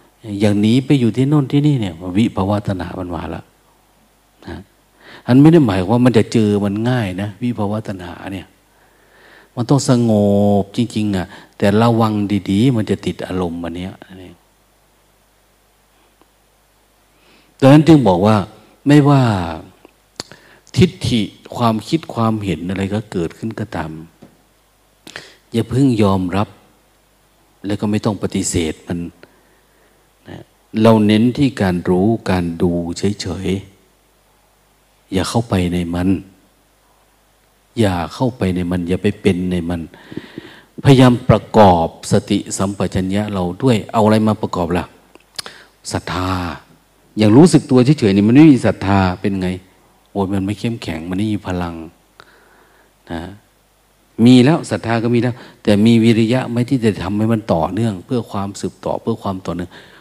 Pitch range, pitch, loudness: 90-115 Hz, 100 Hz, -16 LUFS